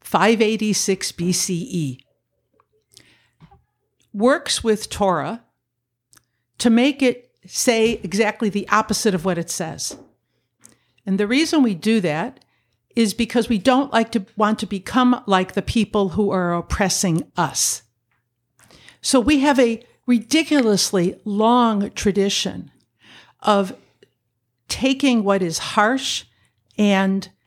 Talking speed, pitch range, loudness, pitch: 110 wpm, 180-230 Hz, -19 LUFS, 210 Hz